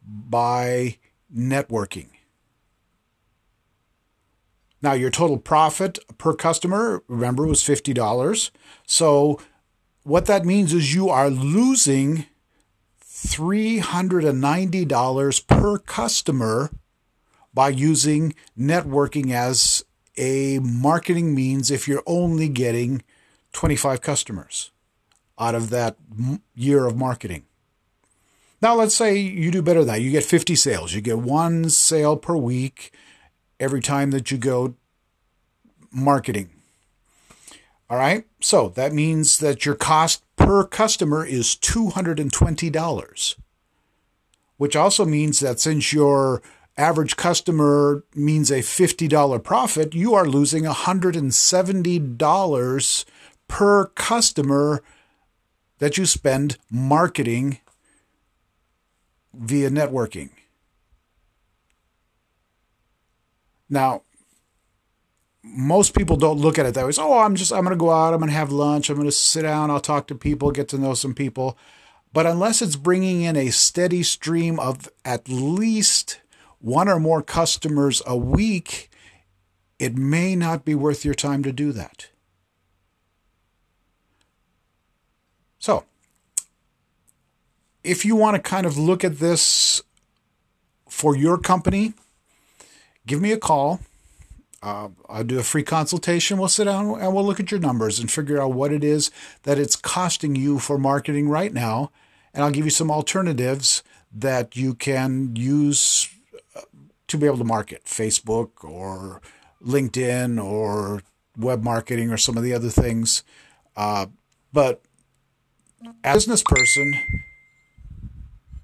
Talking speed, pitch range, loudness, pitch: 125 wpm, 120-160 Hz, -20 LUFS, 140 Hz